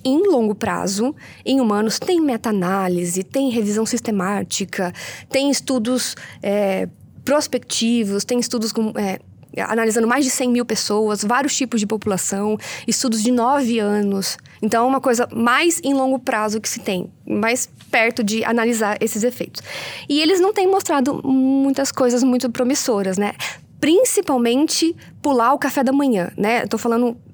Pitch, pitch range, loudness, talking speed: 235 Hz, 210-270 Hz, -19 LUFS, 150 wpm